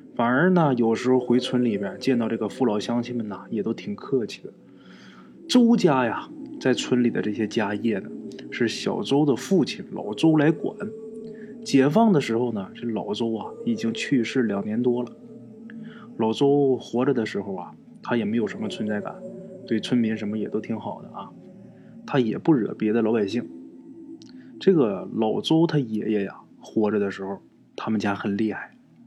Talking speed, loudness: 250 characters per minute, -24 LUFS